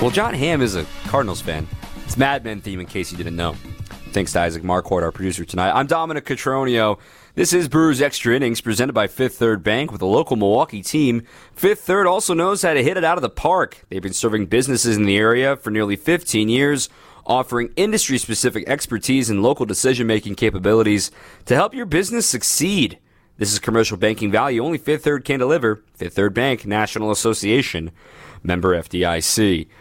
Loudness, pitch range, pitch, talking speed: -19 LUFS, 100-135 Hz, 115 Hz, 190 wpm